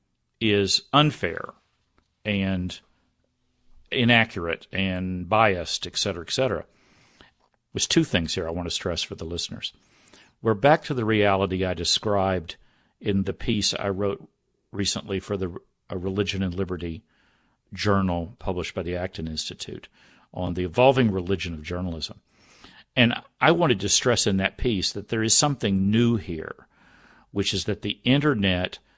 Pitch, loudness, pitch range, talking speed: 95 Hz, -24 LUFS, 90-110 Hz, 145 wpm